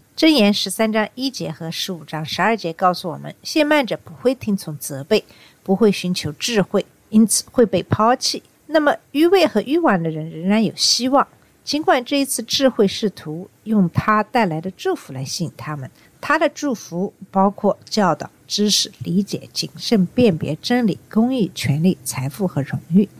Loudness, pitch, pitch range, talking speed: -19 LUFS, 200 Hz, 170-245 Hz, 260 characters per minute